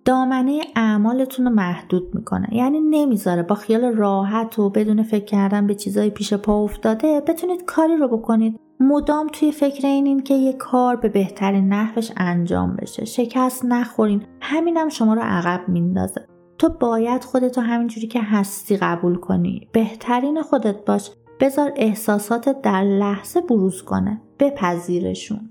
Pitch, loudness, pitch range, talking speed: 225 Hz, -20 LUFS, 200-260 Hz, 145 wpm